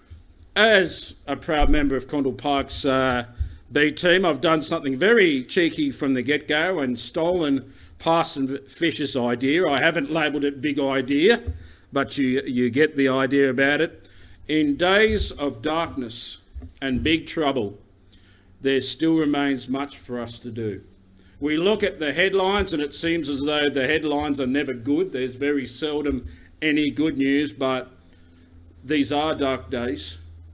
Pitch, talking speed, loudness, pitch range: 140 Hz, 155 wpm, -22 LUFS, 120-150 Hz